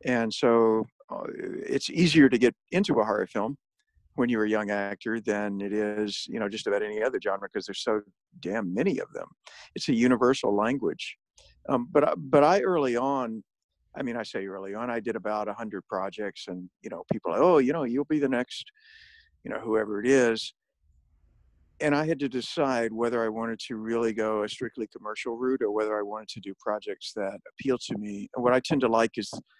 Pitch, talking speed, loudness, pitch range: 115 Hz, 210 wpm, -27 LUFS, 105-130 Hz